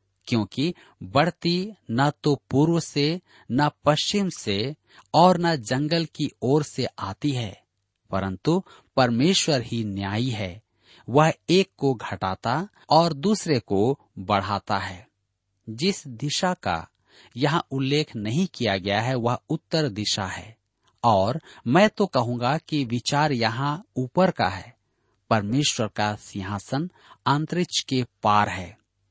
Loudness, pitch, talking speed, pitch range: -24 LUFS, 130 Hz, 125 wpm, 105-155 Hz